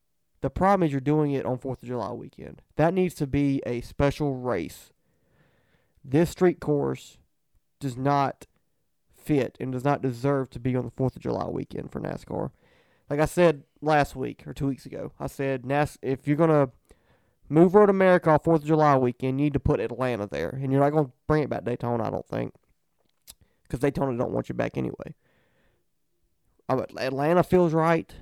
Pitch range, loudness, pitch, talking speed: 130-155 Hz, -25 LUFS, 140 Hz, 195 wpm